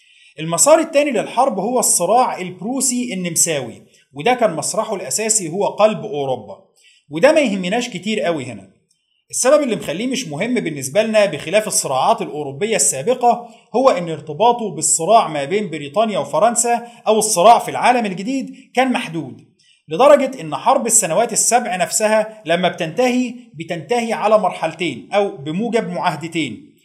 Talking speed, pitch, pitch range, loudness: 135 wpm, 215 Hz, 170-240 Hz, -17 LUFS